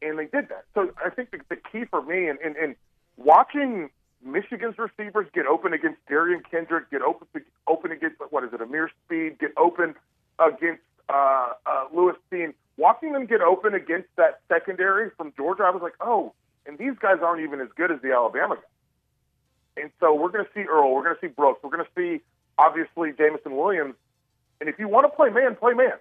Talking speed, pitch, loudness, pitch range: 210 wpm, 180 Hz, -24 LUFS, 160-235 Hz